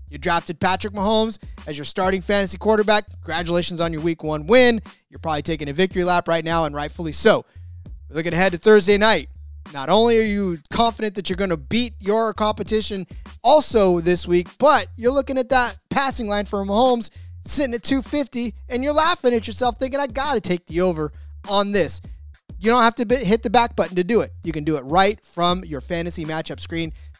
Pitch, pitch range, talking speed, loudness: 190 Hz, 160-230 Hz, 205 wpm, -20 LUFS